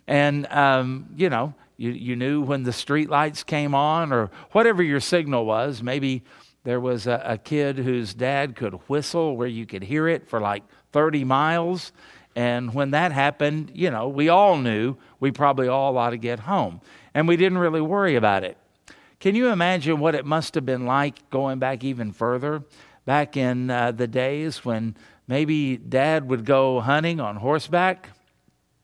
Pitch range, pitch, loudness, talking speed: 125-155 Hz, 140 Hz, -23 LUFS, 175 wpm